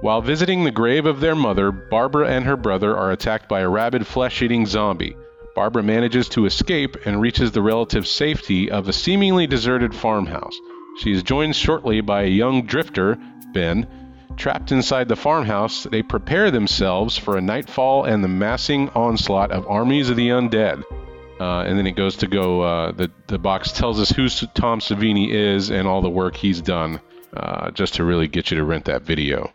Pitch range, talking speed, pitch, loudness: 95-130 Hz, 190 wpm, 110 Hz, -20 LUFS